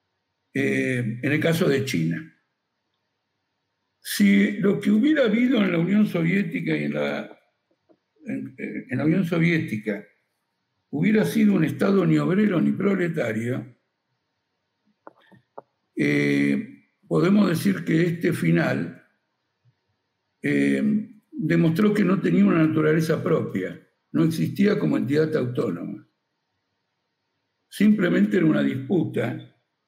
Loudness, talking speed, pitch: -22 LUFS, 110 wpm, 160 Hz